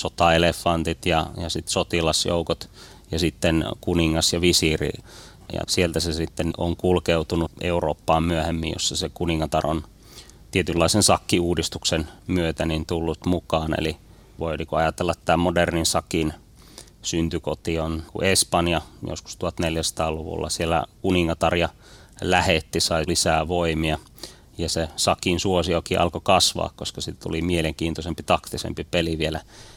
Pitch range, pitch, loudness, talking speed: 80-90 Hz, 85 Hz, -23 LUFS, 120 wpm